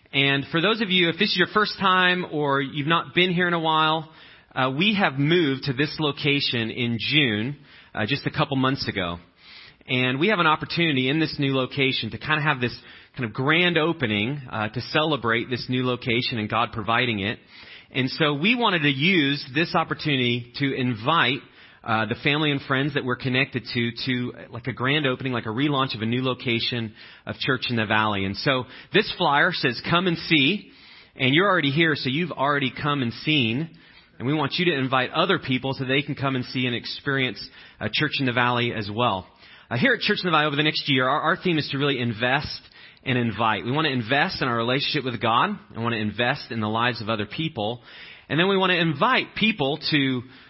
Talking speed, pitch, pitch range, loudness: 220 wpm, 135 Hz, 120-155 Hz, -23 LUFS